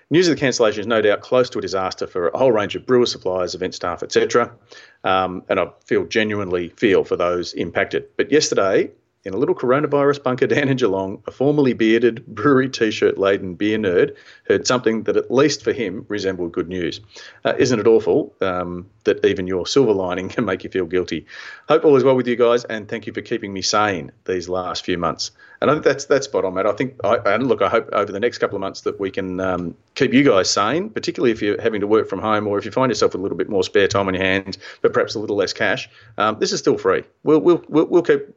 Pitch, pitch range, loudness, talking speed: 115 Hz, 95-150 Hz, -19 LUFS, 245 wpm